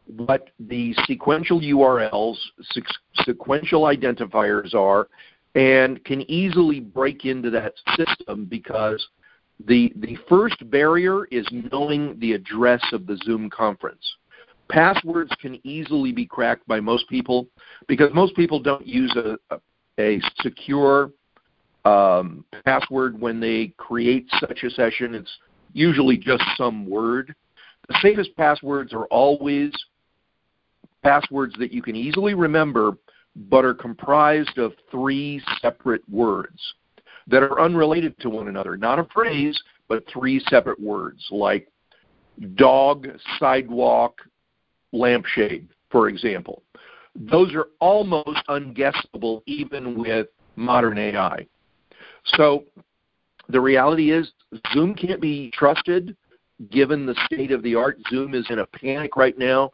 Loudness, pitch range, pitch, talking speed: -21 LUFS, 120-150 Hz, 135 Hz, 125 wpm